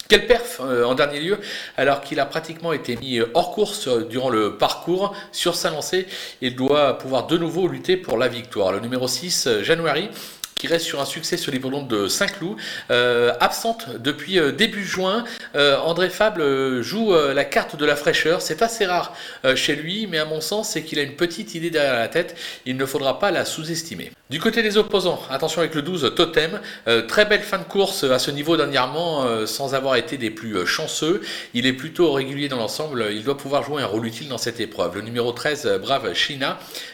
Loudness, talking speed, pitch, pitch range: -21 LUFS, 200 wpm, 155 Hz, 130-185 Hz